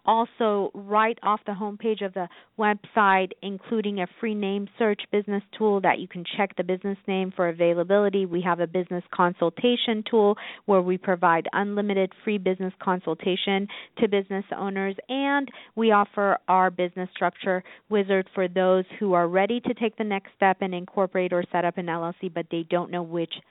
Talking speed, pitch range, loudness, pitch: 175 wpm, 180-205 Hz, -25 LUFS, 195 Hz